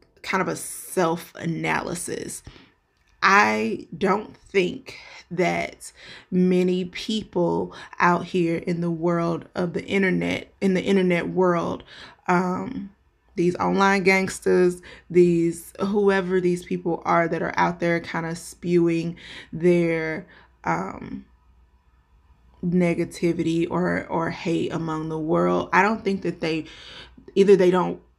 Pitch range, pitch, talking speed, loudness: 165-185 Hz, 175 Hz, 115 wpm, -23 LUFS